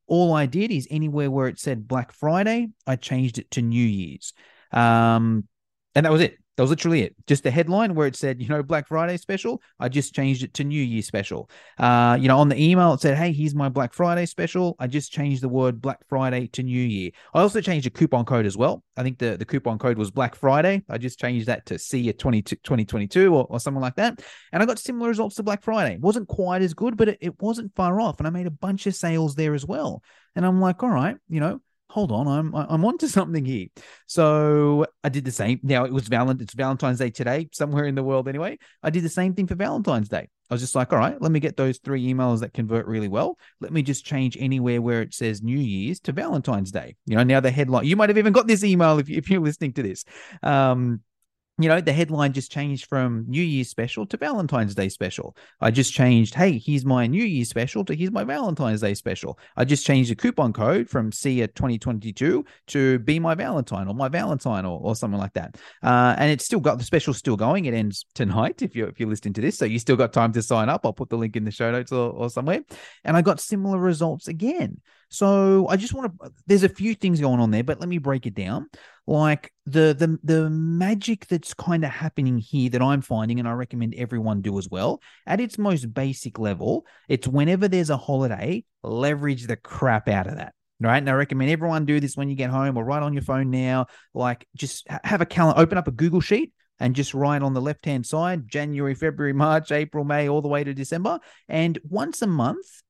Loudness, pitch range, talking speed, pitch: -23 LUFS, 125-165 Hz, 240 wpm, 140 Hz